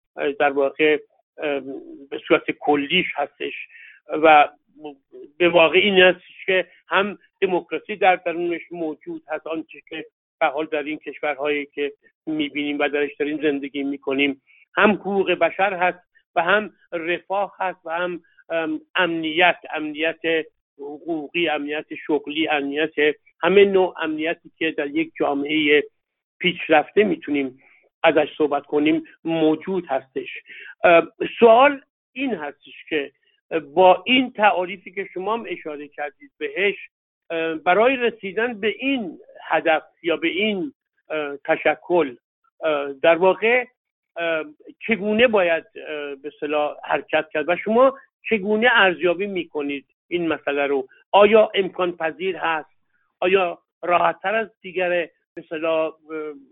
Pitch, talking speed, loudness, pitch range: 165 Hz, 115 wpm, -21 LUFS, 150-195 Hz